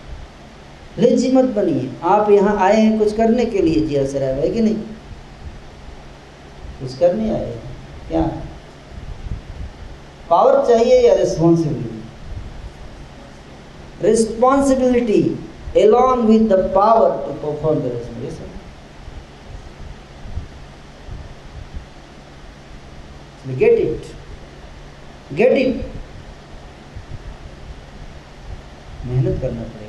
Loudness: -16 LUFS